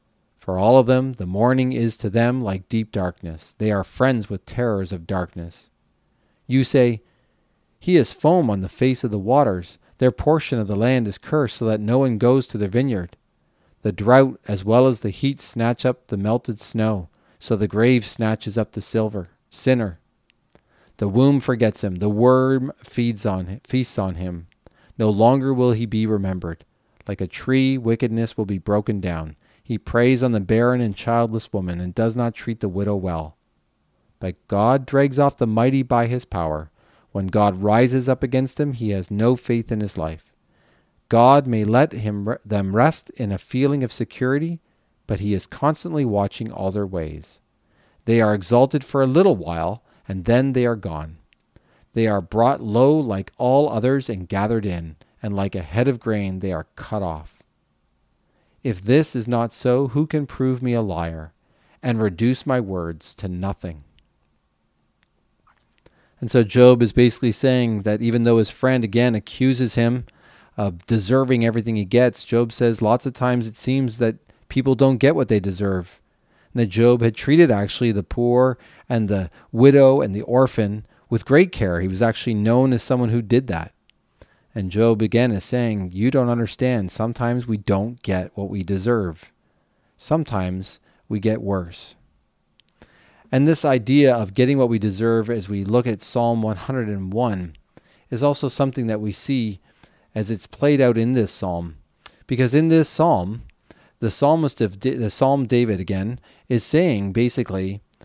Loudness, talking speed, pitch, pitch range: -20 LUFS, 175 wpm, 115 Hz, 100-125 Hz